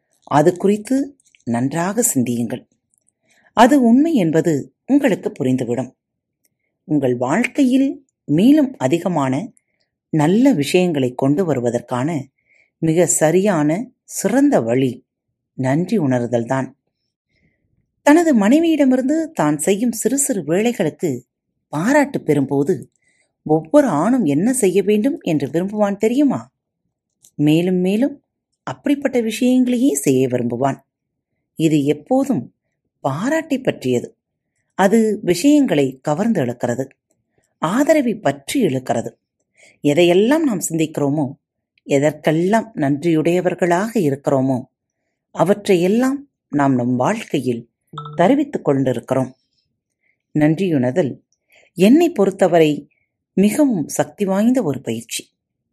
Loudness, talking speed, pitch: -17 LUFS, 85 wpm, 165 Hz